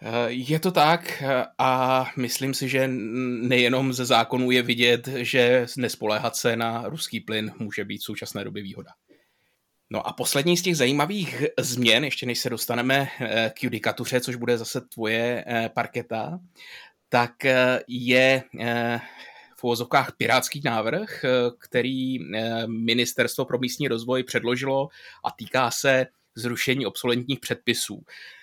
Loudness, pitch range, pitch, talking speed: -24 LUFS, 120-130 Hz, 125 Hz, 125 wpm